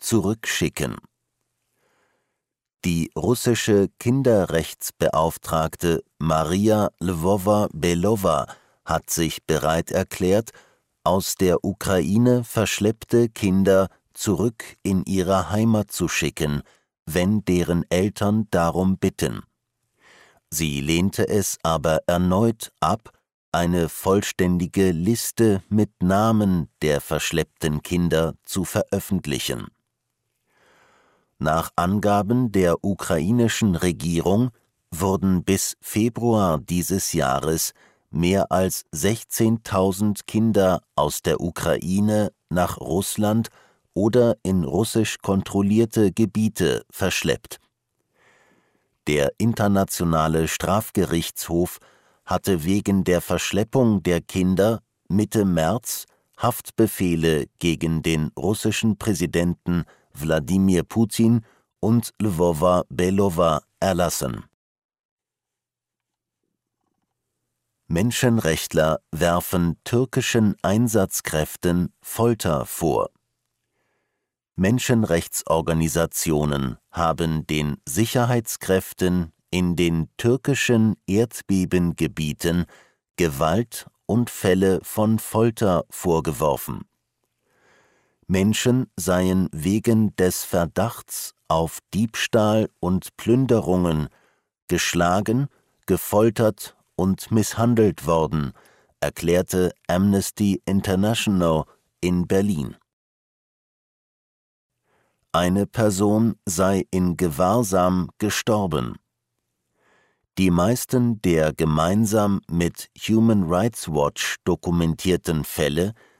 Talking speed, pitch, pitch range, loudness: 75 wpm, 95 Hz, 85-110 Hz, -22 LUFS